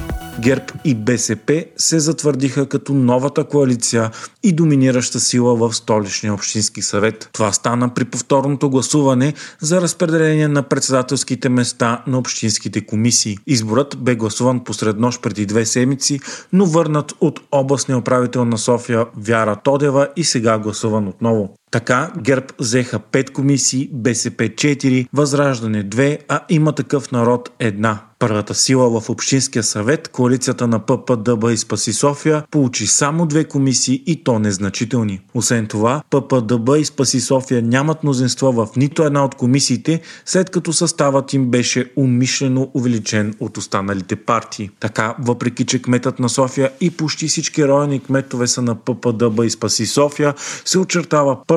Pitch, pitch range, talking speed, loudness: 130 Hz, 115-140 Hz, 145 wpm, -17 LUFS